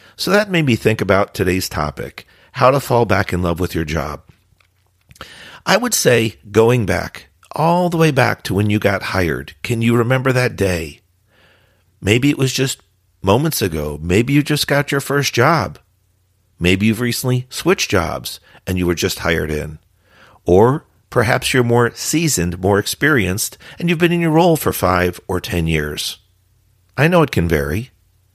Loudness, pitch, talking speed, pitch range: -16 LUFS, 100 Hz, 175 wpm, 90-130 Hz